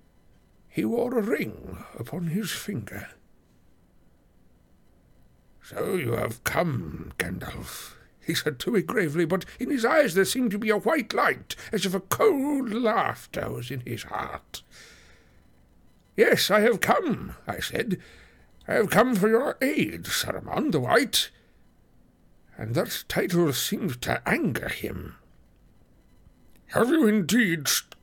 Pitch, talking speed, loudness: 195 Hz, 135 wpm, -26 LUFS